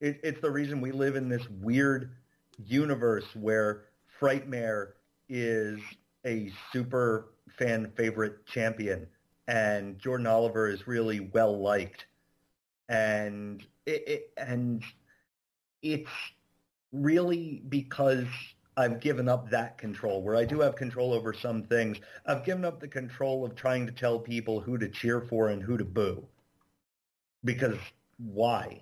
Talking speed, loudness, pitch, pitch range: 135 wpm, -31 LUFS, 120 Hz, 105-130 Hz